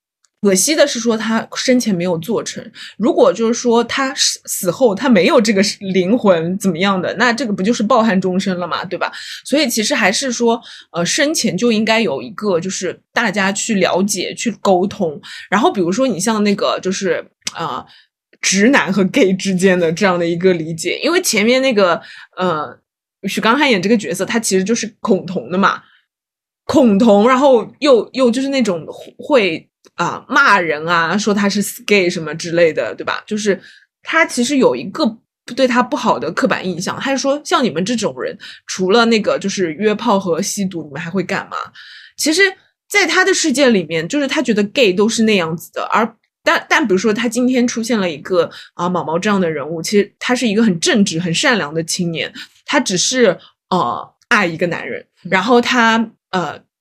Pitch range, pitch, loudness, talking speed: 185-250 Hz, 210 Hz, -15 LUFS, 285 characters per minute